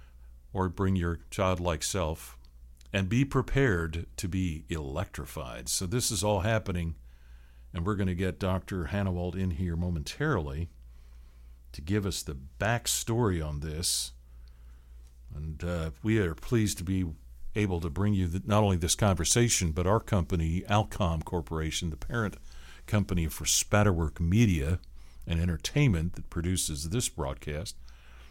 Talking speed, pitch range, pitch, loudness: 140 wpm, 70-95 Hz, 85 Hz, -30 LUFS